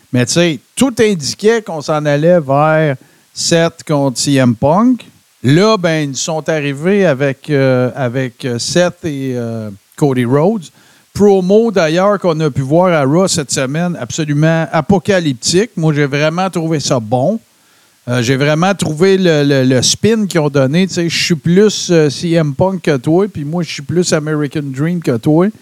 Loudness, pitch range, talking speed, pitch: -13 LUFS, 140-185 Hz, 170 wpm, 160 Hz